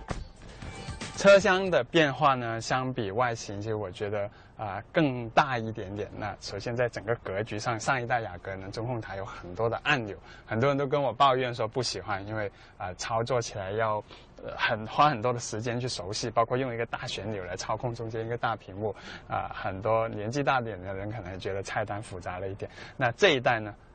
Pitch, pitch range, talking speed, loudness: 115 Hz, 105-125 Hz, 305 characters per minute, -29 LUFS